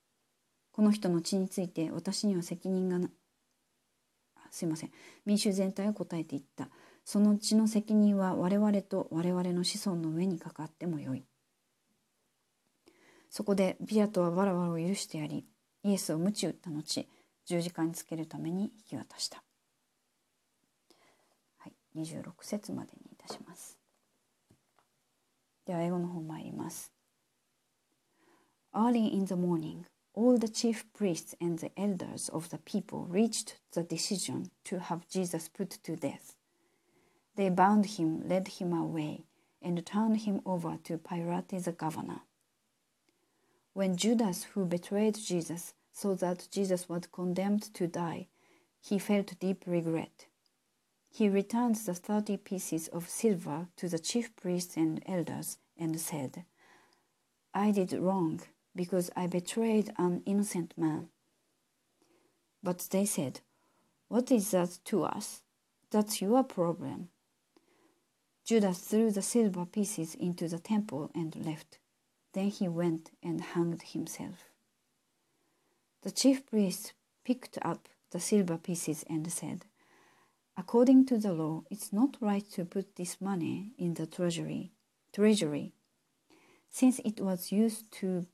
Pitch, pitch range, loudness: 185 Hz, 170-210 Hz, -33 LUFS